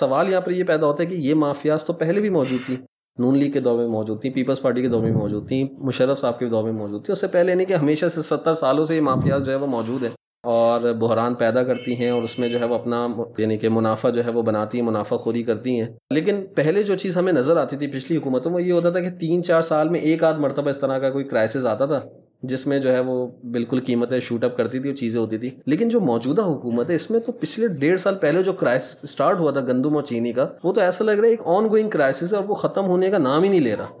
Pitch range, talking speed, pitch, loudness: 120-170 Hz, 290 wpm, 135 Hz, -21 LUFS